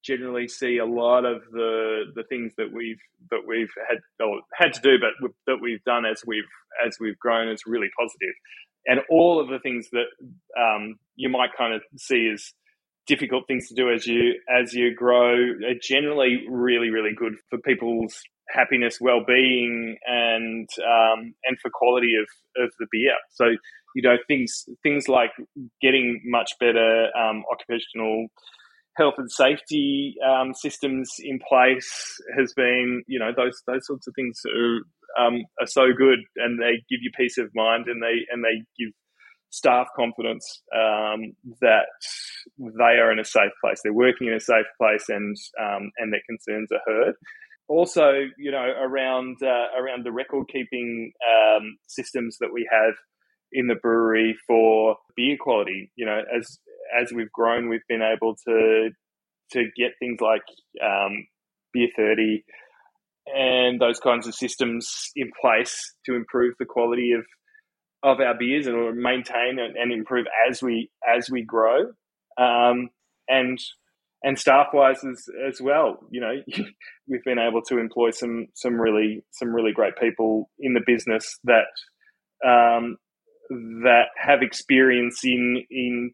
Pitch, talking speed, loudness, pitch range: 120 Hz, 160 wpm, -22 LUFS, 115-130 Hz